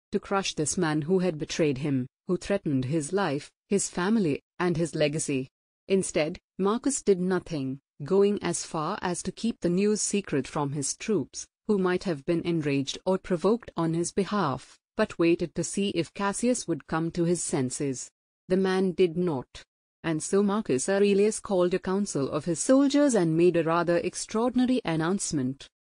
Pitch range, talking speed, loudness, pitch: 160-200 Hz, 170 wpm, -27 LUFS, 180 Hz